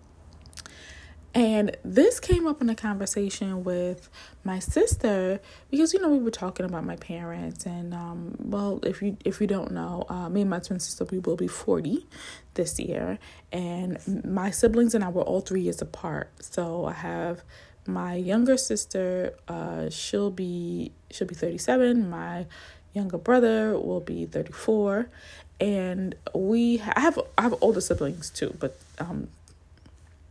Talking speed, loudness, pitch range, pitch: 165 wpm, -27 LUFS, 170-215 Hz, 190 Hz